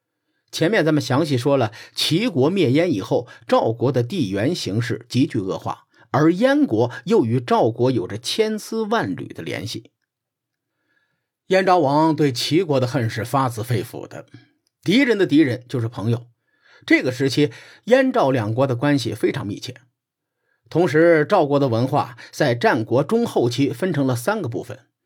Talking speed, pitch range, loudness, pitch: 235 characters per minute, 120-160 Hz, -20 LUFS, 135 Hz